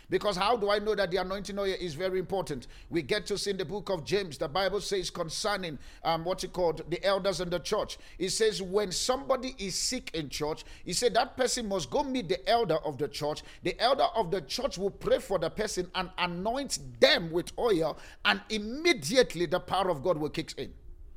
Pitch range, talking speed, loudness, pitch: 170-210 Hz, 220 wpm, -30 LUFS, 190 Hz